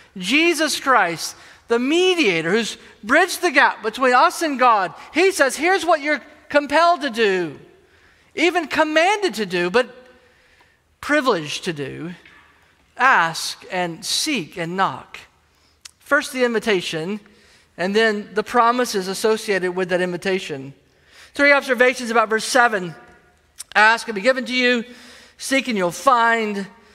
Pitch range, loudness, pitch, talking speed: 195-290 Hz, -18 LUFS, 235 Hz, 130 wpm